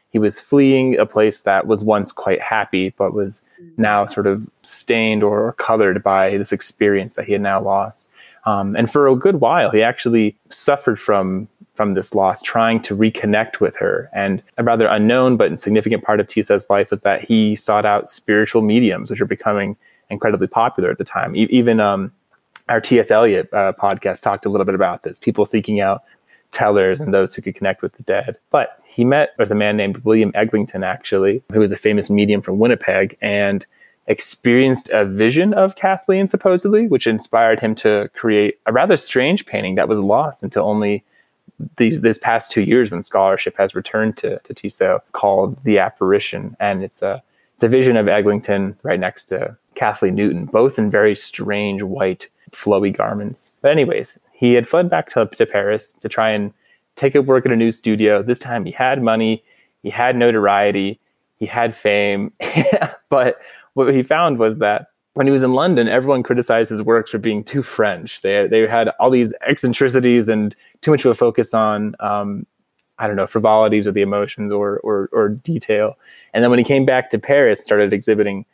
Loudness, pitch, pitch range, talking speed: -17 LUFS, 110 Hz, 105-120 Hz, 195 wpm